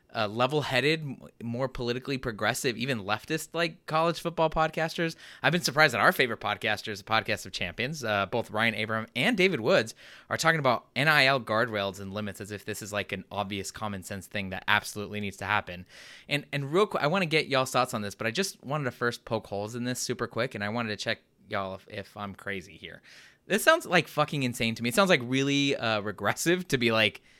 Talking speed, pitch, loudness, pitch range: 225 wpm, 120 Hz, -28 LUFS, 105-145 Hz